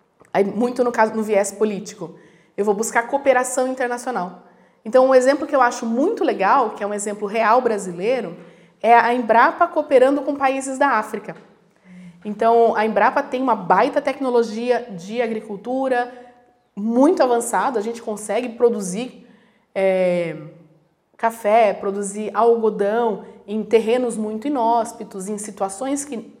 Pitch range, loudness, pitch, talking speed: 205-245 Hz, -19 LUFS, 225 Hz, 135 wpm